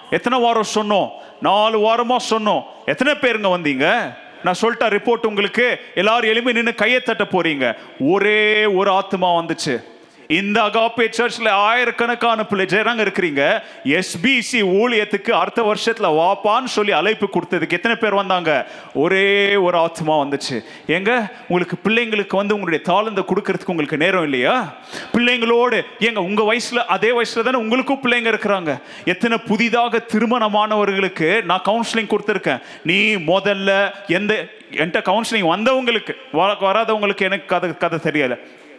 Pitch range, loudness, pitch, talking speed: 190-230 Hz, -17 LUFS, 210 Hz, 125 wpm